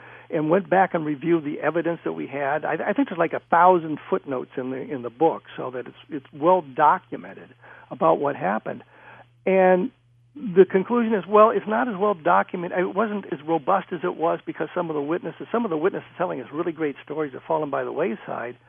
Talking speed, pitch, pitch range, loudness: 220 wpm, 170 Hz, 150-190 Hz, -23 LUFS